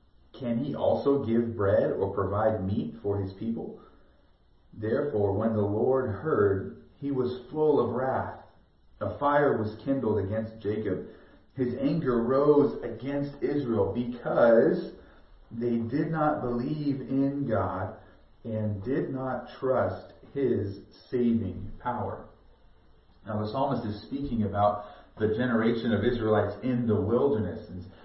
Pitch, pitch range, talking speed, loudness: 115 Hz, 105-130 Hz, 125 wpm, -28 LUFS